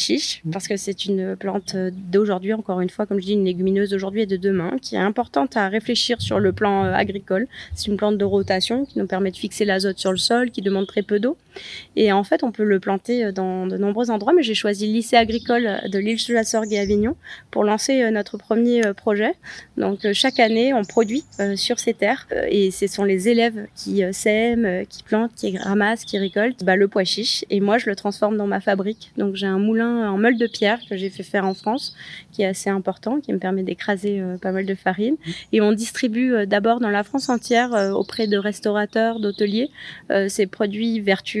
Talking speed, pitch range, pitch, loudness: 215 wpm, 195-230 Hz, 210 Hz, -21 LUFS